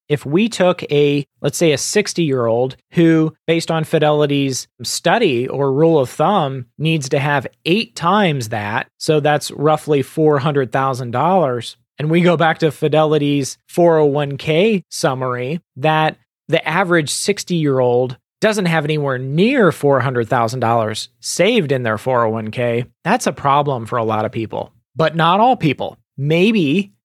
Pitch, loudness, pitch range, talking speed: 150 Hz, -16 LUFS, 130-165 Hz, 145 wpm